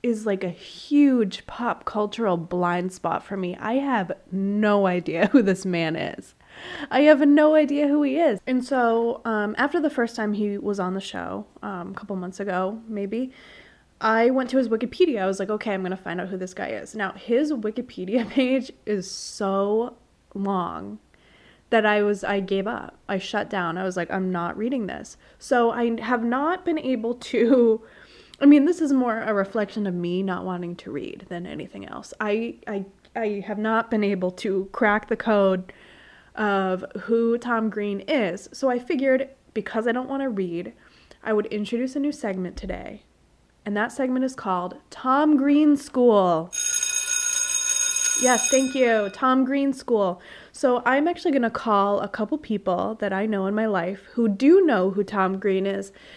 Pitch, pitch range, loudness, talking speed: 215 Hz, 195-260 Hz, -23 LUFS, 185 wpm